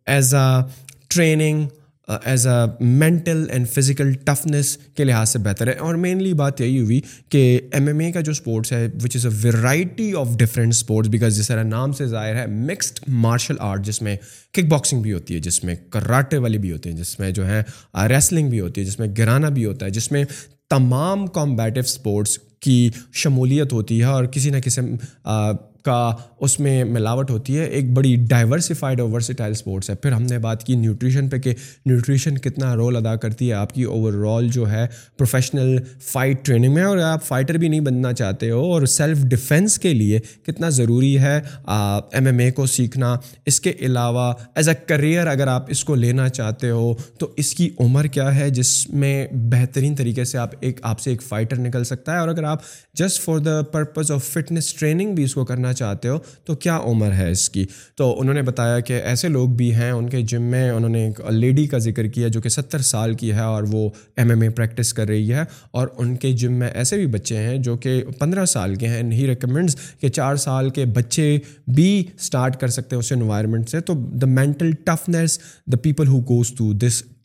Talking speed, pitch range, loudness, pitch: 210 wpm, 115-145 Hz, -19 LUFS, 125 Hz